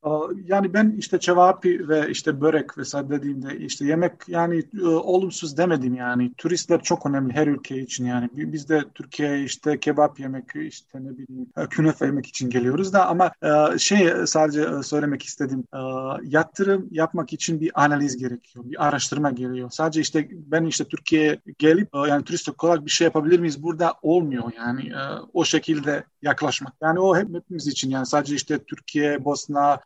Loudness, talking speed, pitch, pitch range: -22 LUFS, 160 wpm, 150 Hz, 140-170 Hz